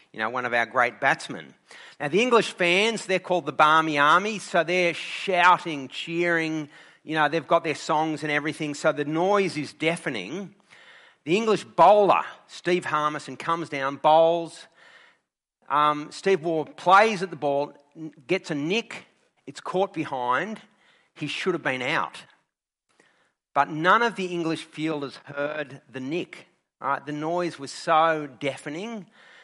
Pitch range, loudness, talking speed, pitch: 150-180 Hz, -24 LUFS, 150 wpm, 160 Hz